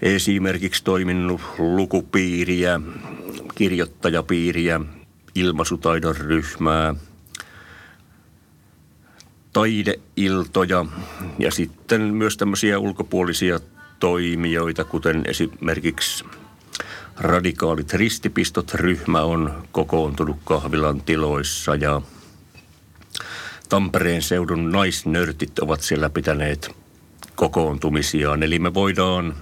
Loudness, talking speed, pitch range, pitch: -21 LUFS, 65 wpm, 80-95 Hz, 85 Hz